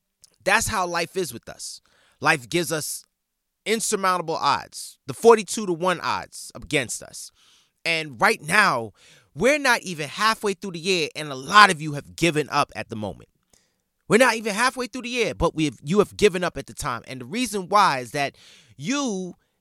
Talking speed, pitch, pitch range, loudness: 195 wpm, 175 Hz, 145-210 Hz, -22 LUFS